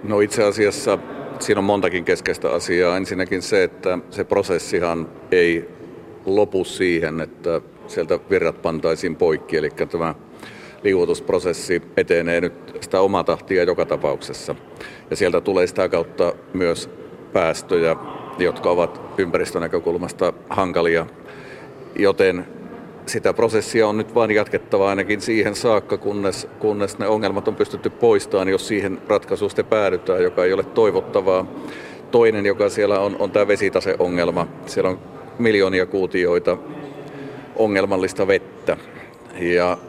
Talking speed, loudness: 120 wpm, -20 LUFS